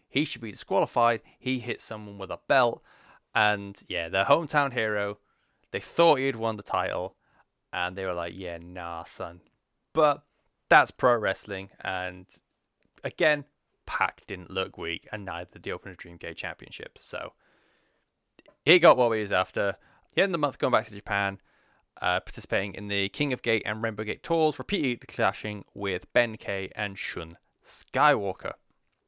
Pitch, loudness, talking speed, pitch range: 105 Hz, -27 LUFS, 170 wpm, 95-120 Hz